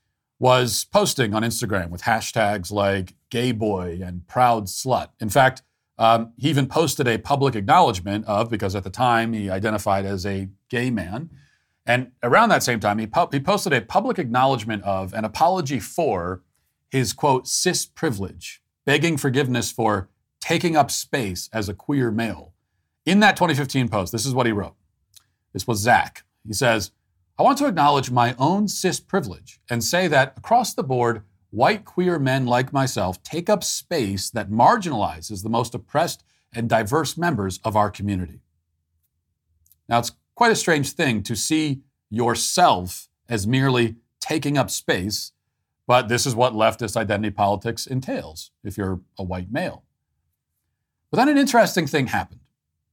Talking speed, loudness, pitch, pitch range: 160 wpm, -21 LUFS, 115 Hz, 100-135 Hz